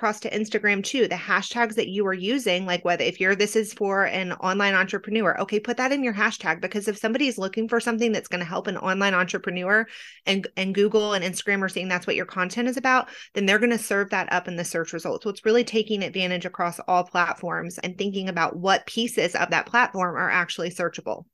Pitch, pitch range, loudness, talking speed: 200 Hz, 180-220 Hz, -24 LUFS, 225 wpm